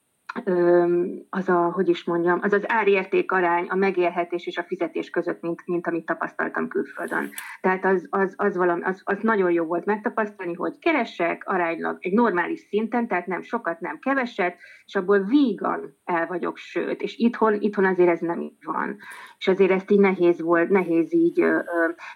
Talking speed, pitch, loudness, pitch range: 180 wpm, 185 Hz, -23 LUFS, 175-205 Hz